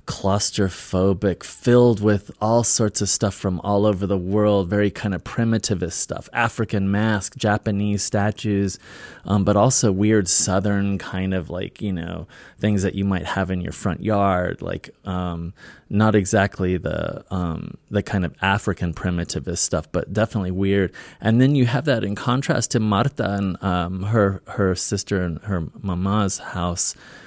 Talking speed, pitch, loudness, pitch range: 160 wpm, 100 Hz, -21 LUFS, 95-105 Hz